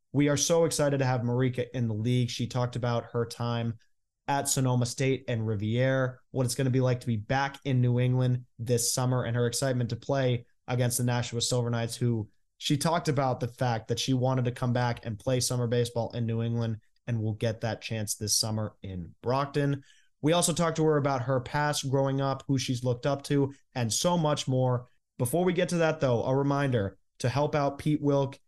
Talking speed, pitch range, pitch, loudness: 220 wpm, 120-140 Hz, 125 Hz, -28 LUFS